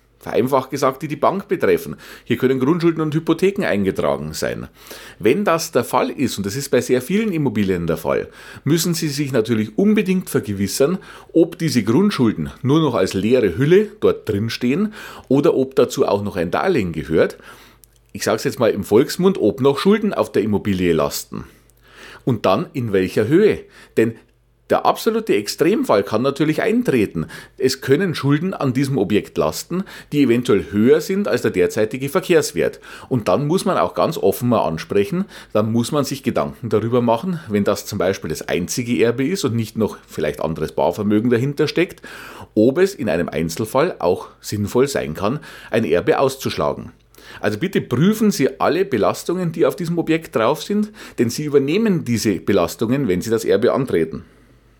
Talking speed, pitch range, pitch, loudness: 175 wpm, 110-185 Hz, 140 Hz, -19 LUFS